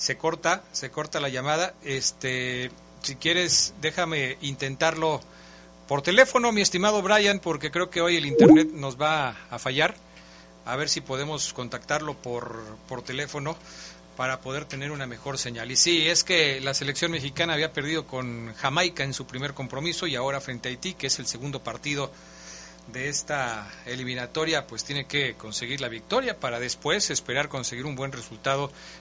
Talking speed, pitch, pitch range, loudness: 170 wpm, 140 Hz, 125-155 Hz, -25 LUFS